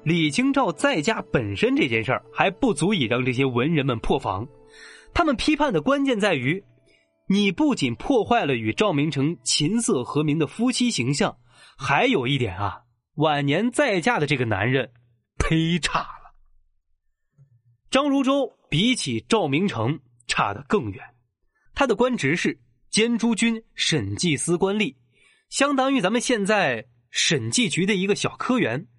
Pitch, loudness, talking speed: 155 Hz, -22 LUFS, 225 characters per minute